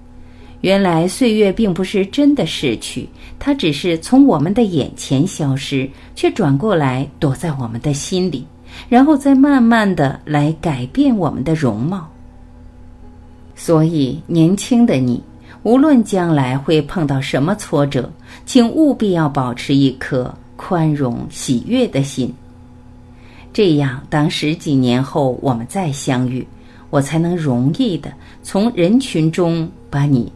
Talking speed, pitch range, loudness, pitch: 200 characters per minute, 125-190 Hz, -16 LUFS, 150 Hz